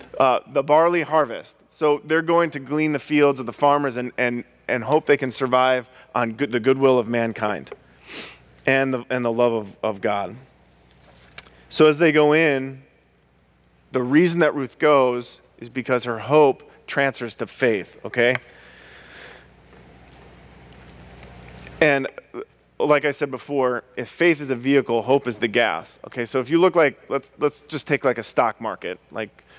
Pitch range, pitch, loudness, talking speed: 115-145 Hz, 130 Hz, -21 LUFS, 165 wpm